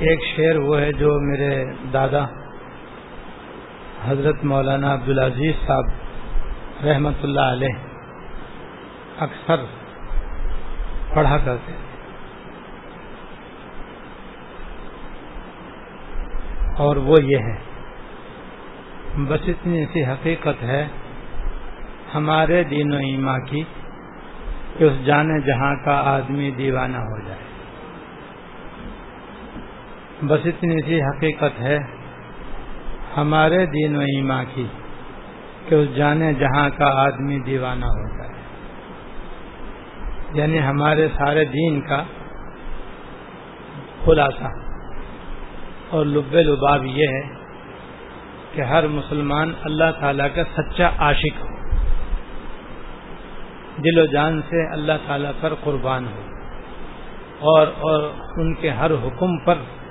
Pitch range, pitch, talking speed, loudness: 135-155 Hz, 145 Hz, 95 wpm, -20 LUFS